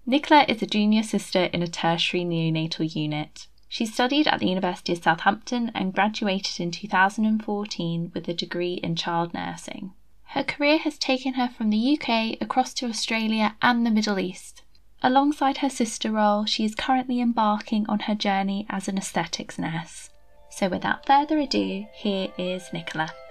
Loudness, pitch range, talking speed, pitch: -24 LUFS, 180-245 Hz, 165 wpm, 210 Hz